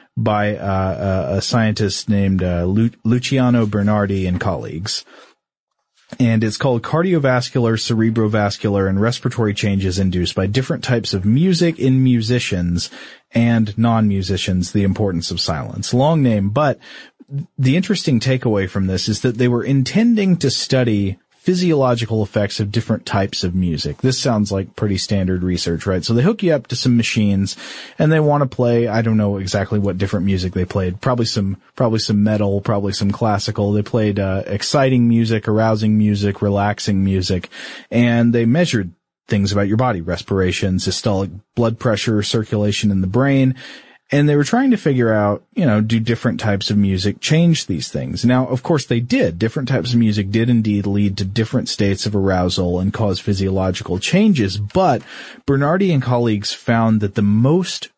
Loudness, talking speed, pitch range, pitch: -17 LUFS, 170 wpm, 100-125 Hz, 110 Hz